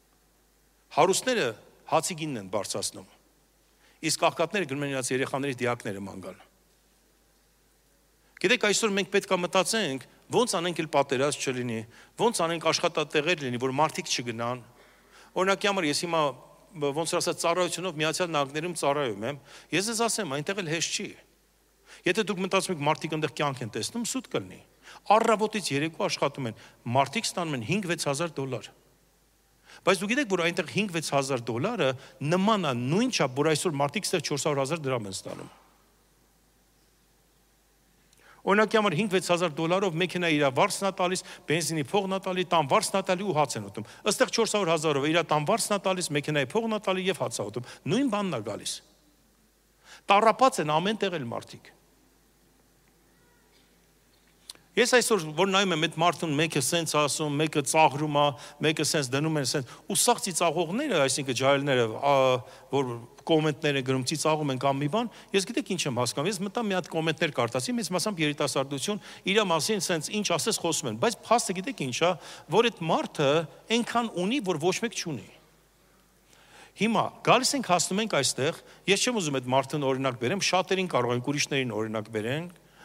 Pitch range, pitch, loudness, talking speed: 140-195 Hz, 165 Hz, -27 LUFS, 155 wpm